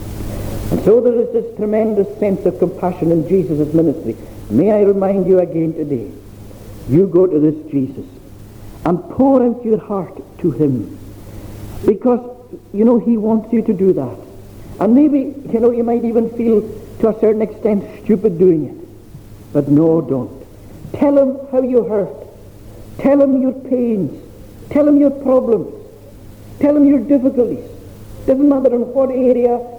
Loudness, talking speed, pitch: -15 LUFS, 160 wpm, 195 Hz